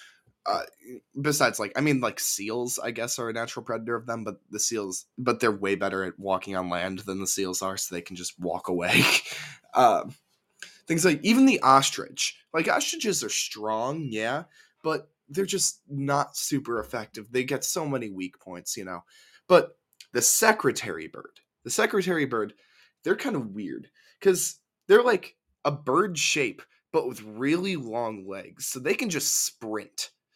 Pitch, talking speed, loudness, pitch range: 115 Hz, 175 wpm, -26 LUFS, 100-150 Hz